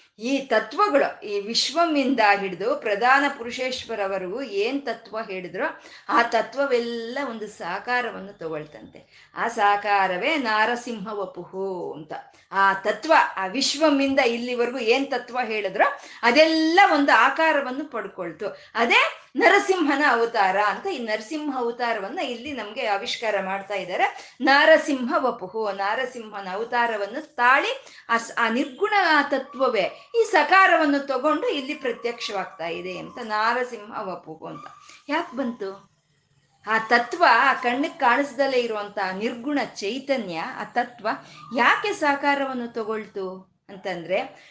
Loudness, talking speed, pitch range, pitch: -22 LUFS, 105 wpm, 200-280 Hz, 235 Hz